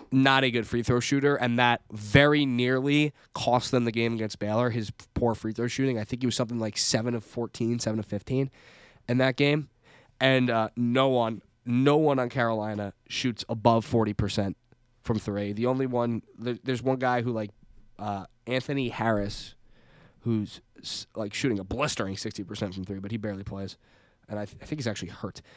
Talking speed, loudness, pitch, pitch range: 190 wpm, -27 LUFS, 120 Hz, 105-130 Hz